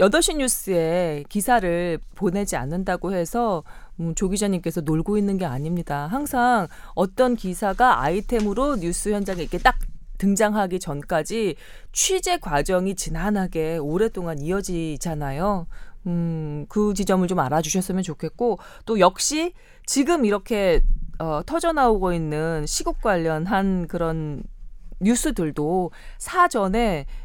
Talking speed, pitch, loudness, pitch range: 270 characters per minute, 190 Hz, -23 LUFS, 165-220 Hz